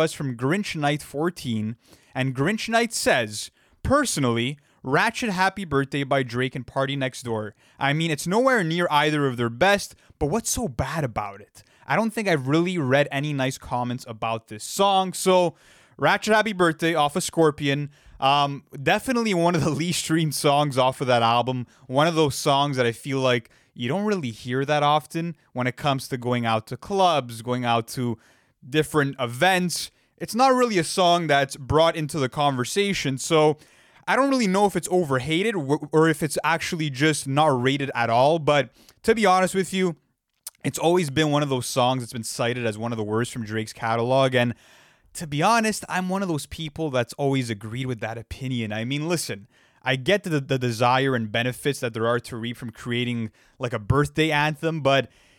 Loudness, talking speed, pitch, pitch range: -23 LUFS, 195 wpm, 140 Hz, 125-165 Hz